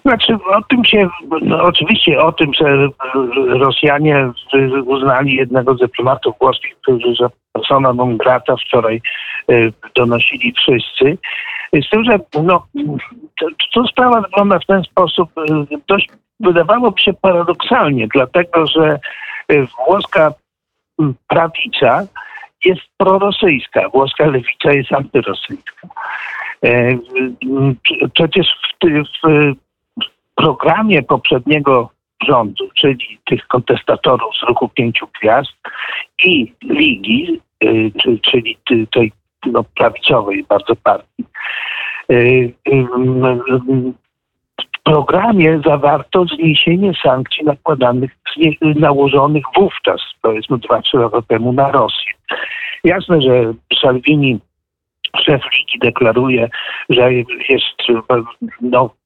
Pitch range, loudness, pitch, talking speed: 130-190 Hz, -13 LUFS, 150 Hz, 100 wpm